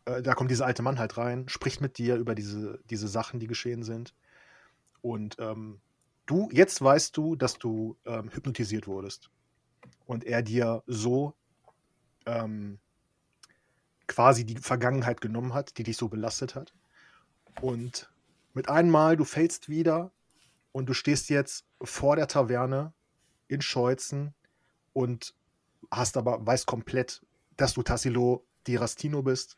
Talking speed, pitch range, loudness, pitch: 140 wpm, 115-140 Hz, -29 LUFS, 125 Hz